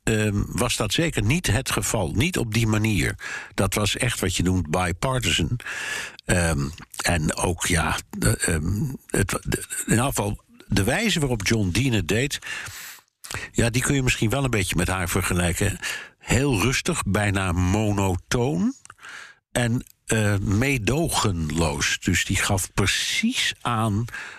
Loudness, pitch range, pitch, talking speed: -23 LUFS, 95-125 Hz, 110 Hz, 145 wpm